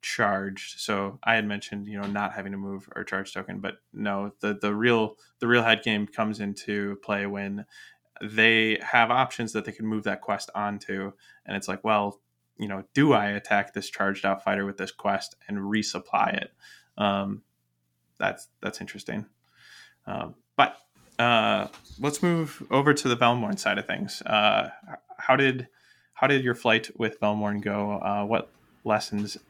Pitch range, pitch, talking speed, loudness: 100-115 Hz, 105 Hz, 175 wpm, -26 LUFS